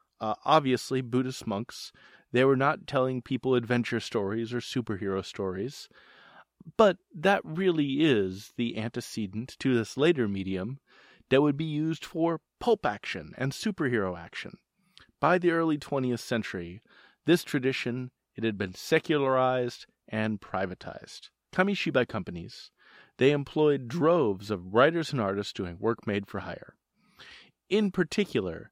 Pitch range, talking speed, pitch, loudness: 110-155 Hz, 125 wpm, 130 Hz, -28 LUFS